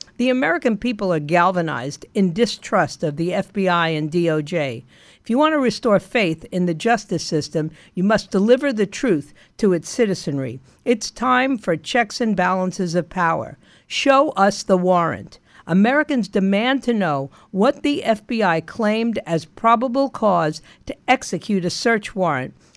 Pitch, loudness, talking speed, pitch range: 190 Hz, -20 LUFS, 170 wpm, 165-235 Hz